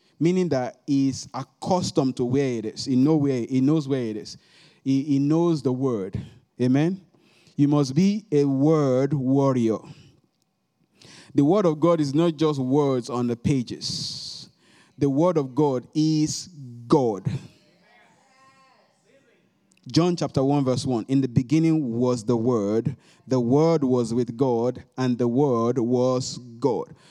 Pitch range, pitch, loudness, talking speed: 125-155 Hz, 140 Hz, -23 LUFS, 145 wpm